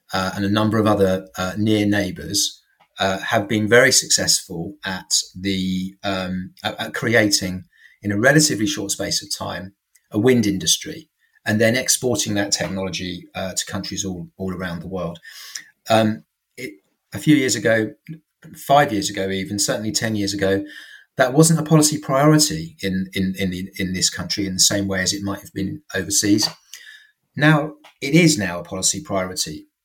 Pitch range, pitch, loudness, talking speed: 95-130 Hz, 100 Hz, -19 LUFS, 170 wpm